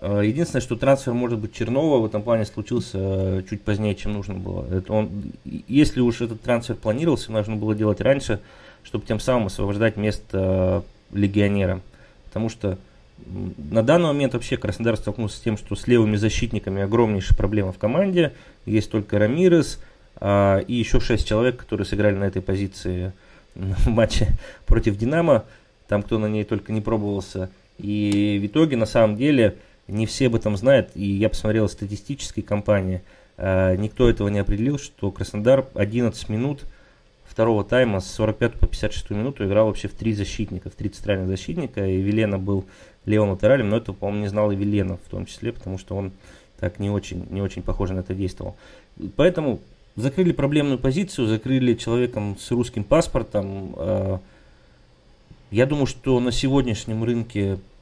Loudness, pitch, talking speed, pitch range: -23 LUFS, 105 Hz, 165 wpm, 100-120 Hz